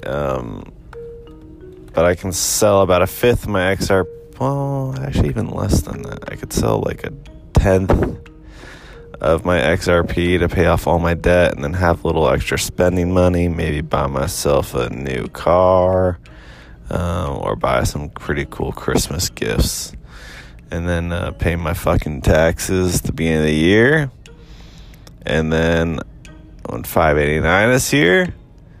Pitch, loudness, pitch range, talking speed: 90 Hz, -17 LUFS, 80-95 Hz, 150 wpm